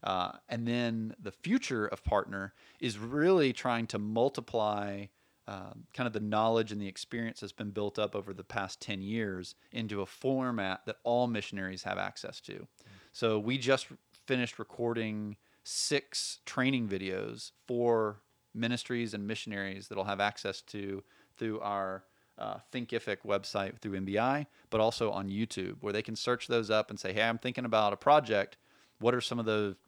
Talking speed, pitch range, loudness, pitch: 170 wpm, 100-120 Hz, -33 LUFS, 110 Hz